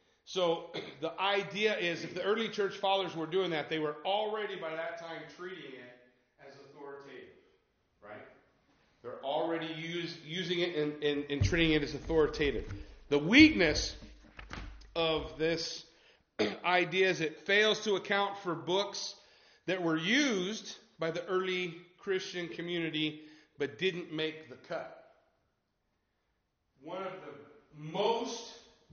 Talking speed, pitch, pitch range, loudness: 130 wpm, 170 Hz, 155-195 Hz, -32 LUFS